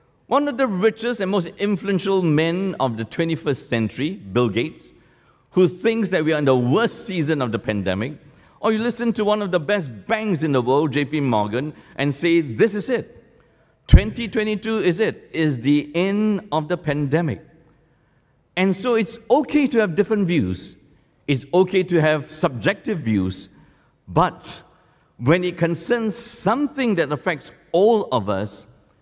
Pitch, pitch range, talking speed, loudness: 165 Hz, 140-205 Hz, 160 wpm, -21 LUFS